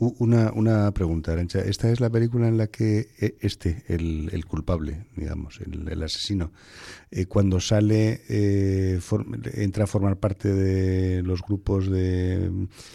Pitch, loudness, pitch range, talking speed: 100 Hz, -25 LUFS, 90-105 Hz, 150 wpm